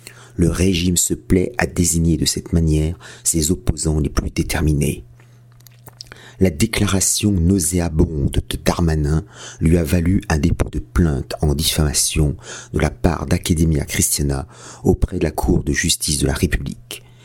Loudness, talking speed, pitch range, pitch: -18 LUFS, 145 wpm, 75-95 Hz, 85 Hz